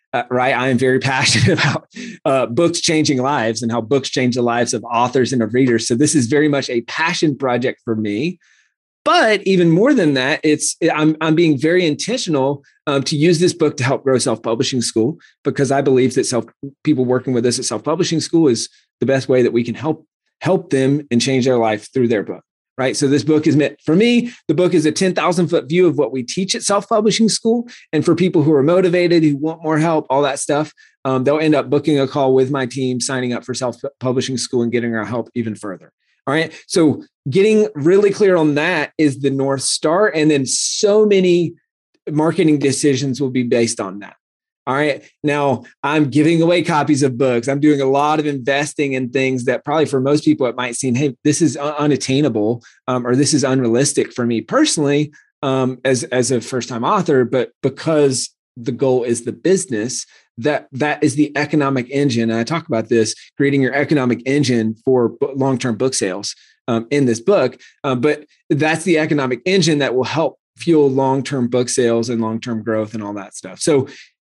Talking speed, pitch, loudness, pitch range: 215 wpm, 140 Hz, -17 LUFS, 125-155 Hz